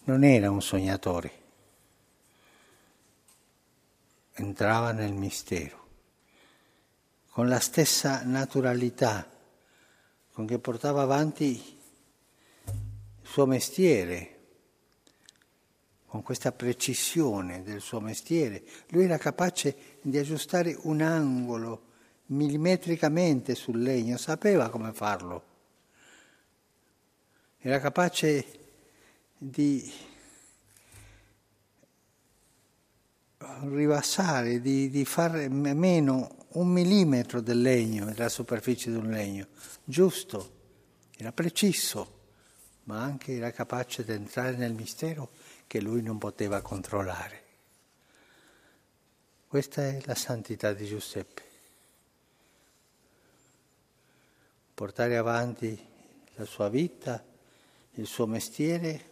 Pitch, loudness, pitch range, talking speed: 125 Hz, -29 LUFS, 110-145 Hz, 85 wpm